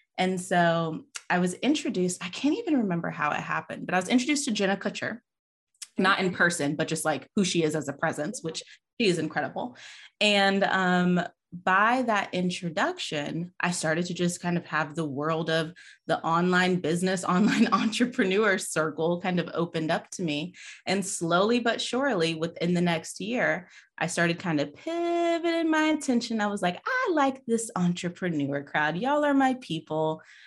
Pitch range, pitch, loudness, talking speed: 165-230 Hz, 180 Hz, -27 LUFS, 175 wpm